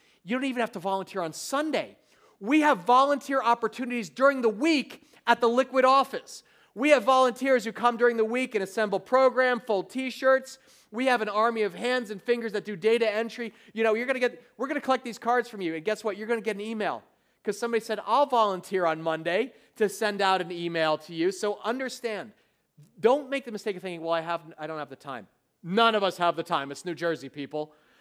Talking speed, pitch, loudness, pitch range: 230 wpm, 225 Hz, -26 LUFS, 190-250 Hz